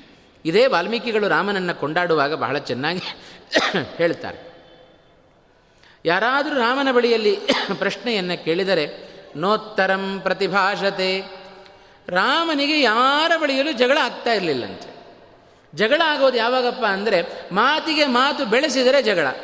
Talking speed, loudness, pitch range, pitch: 85 wpm, -19 LUFS, 195-270 Hz, 225 Hz